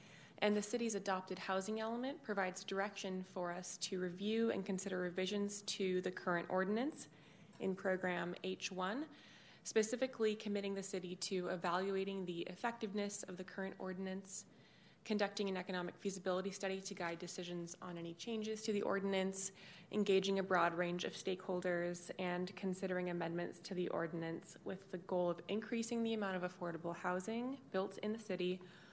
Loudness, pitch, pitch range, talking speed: -41 LUFS, 190 Hz, 180-205 Hz, 155 wpm